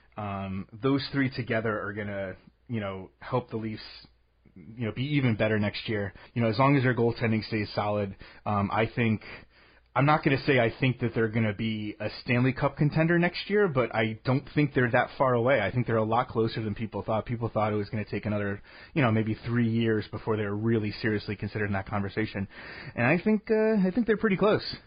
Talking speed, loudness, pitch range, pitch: 220 wpm, -28 LUFS, 105-130 Hz, 110 Hz